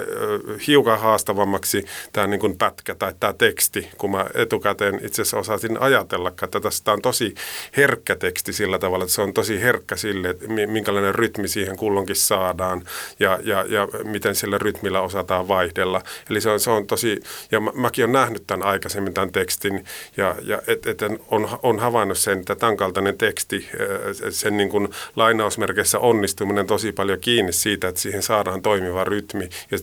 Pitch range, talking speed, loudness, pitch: 95-110 Hz, 165 wpm, -21 LUFS, 100 Hz